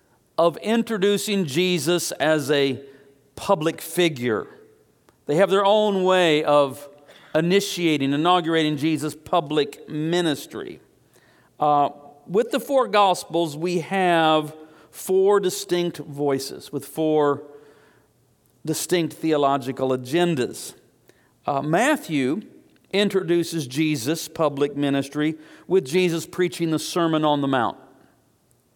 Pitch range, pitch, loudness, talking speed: 145-180 Hz, 160 Hz, -22 LUFS, 100 wpm